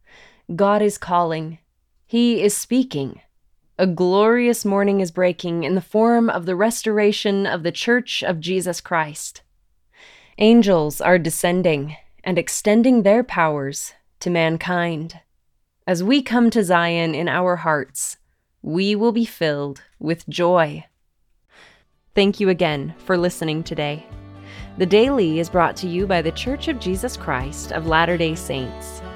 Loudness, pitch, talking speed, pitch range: -19 LUFS, 180 Hz, 140 wpm, 160-205 Hz